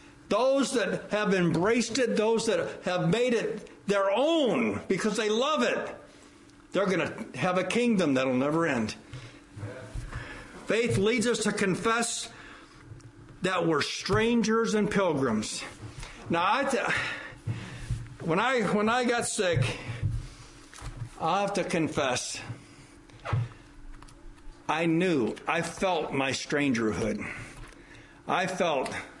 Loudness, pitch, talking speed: -28 LUFS, 185 Hz, 115 wpm